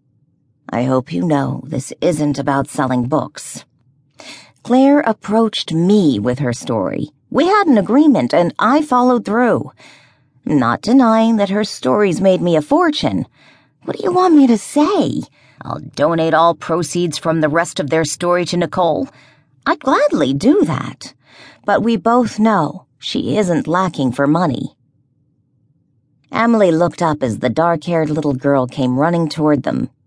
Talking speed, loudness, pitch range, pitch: 155 wpm, -15 LUFS, 140-225 Hz, 170 Hz